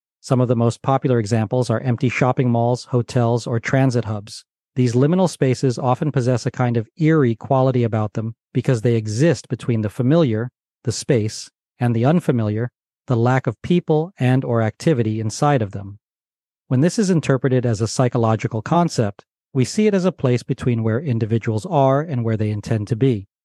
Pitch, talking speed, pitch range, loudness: 125 Hz, 180 wpm, 115-135 Hz, -19 LUFS